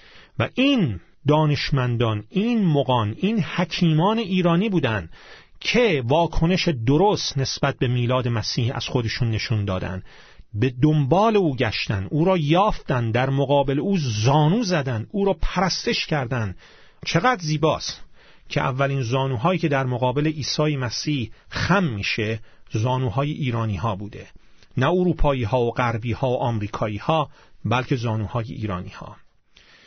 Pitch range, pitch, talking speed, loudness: 115-165 Hz, 135 Hz, 130 wpm, -22 LUFS